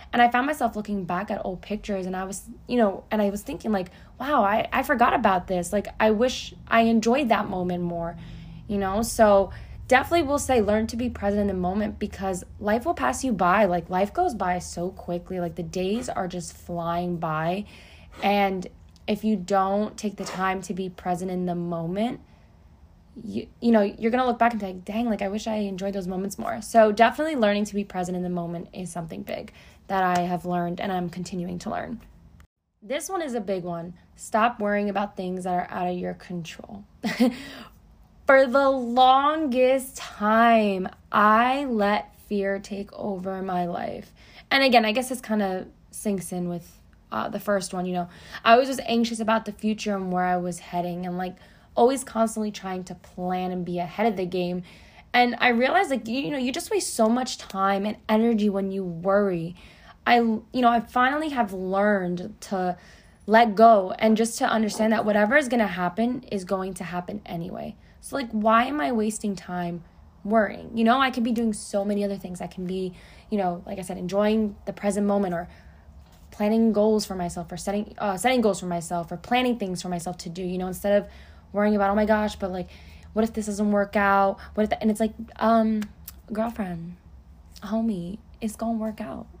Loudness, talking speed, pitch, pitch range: -25 LUFS, 210 wpm, 205 Hz, 185-225 Hz